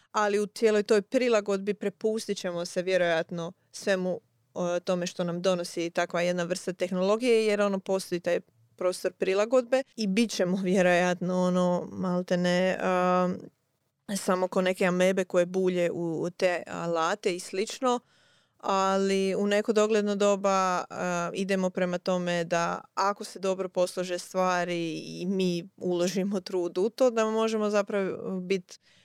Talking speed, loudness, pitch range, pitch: 145 wpm, -28 LUFS, 175-200 Hz, 185 Hz